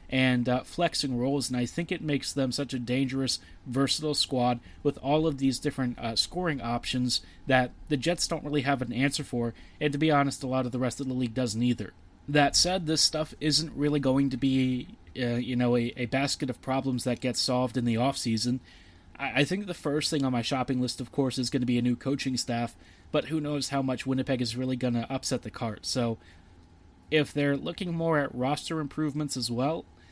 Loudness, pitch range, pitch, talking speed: -28 LUFS, 120-145 Hz, 130 Hz, 225 wpm